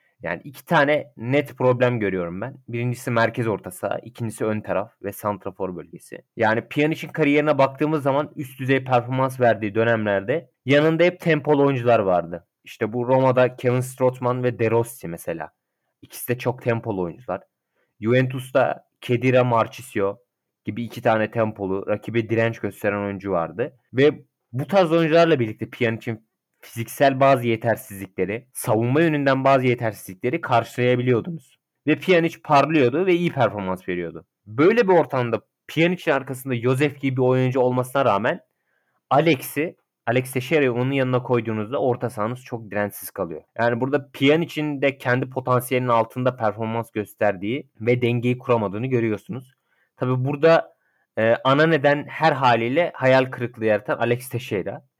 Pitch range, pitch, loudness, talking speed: 115-135 Hz, 125 Hz, -22 LUFS, 135 wpm